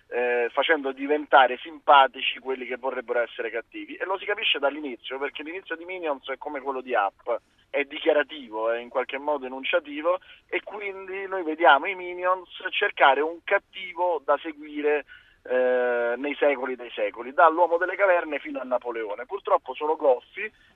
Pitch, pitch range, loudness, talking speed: 150 Hz, 130-185 Hz, -25 LUFS, 160 wpm